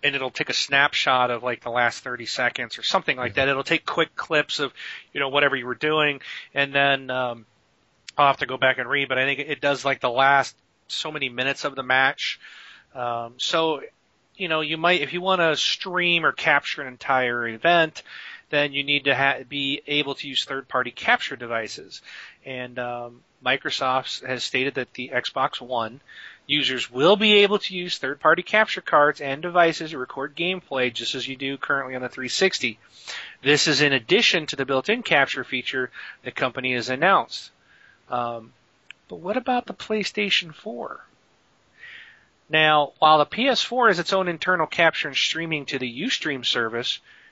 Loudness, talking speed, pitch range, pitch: -22 LUFS, 185 wpm, 130-165 Hz, 140 Hz